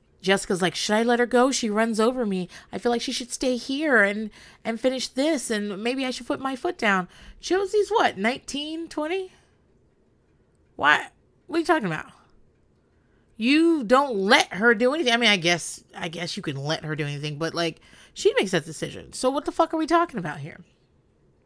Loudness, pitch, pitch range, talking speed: -24 LUFS, 240 Hz, 185-290 Hz, 205 wpm